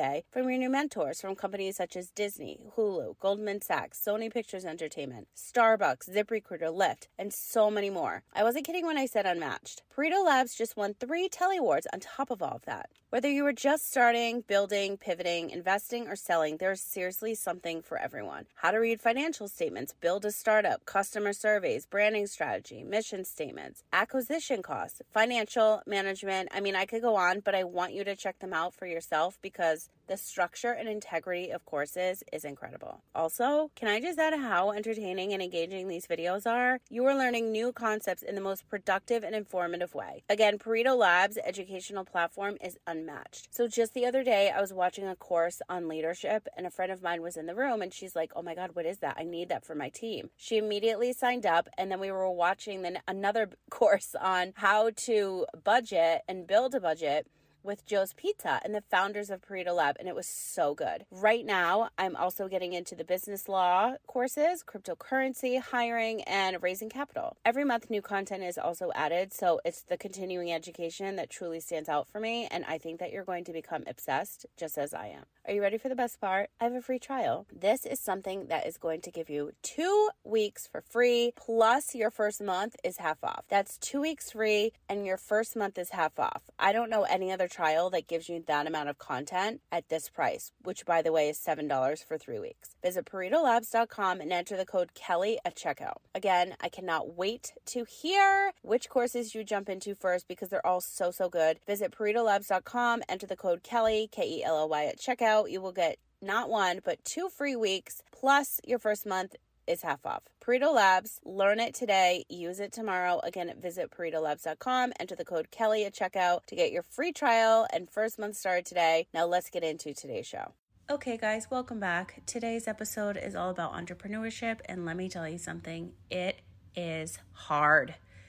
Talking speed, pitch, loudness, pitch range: 200 wpm, 200 Hz, -31 LUFS, 180-230 Hz